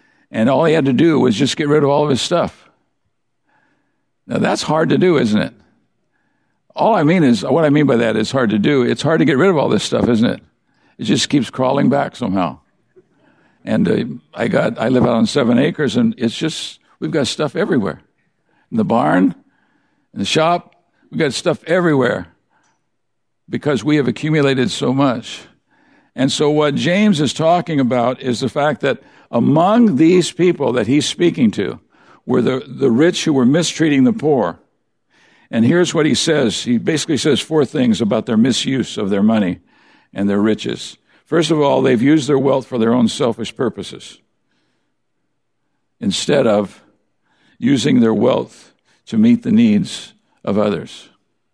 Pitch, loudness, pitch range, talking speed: 155 Hz, -16 LUFS, 135-195 Hz, 180 wpm